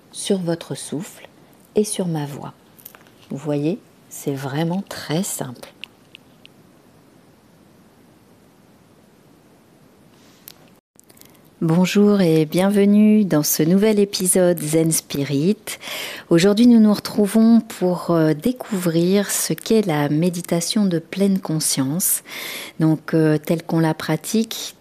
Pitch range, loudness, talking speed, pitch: 155-205 Hz, -19 LUFS, 100 wpm, 175 Hz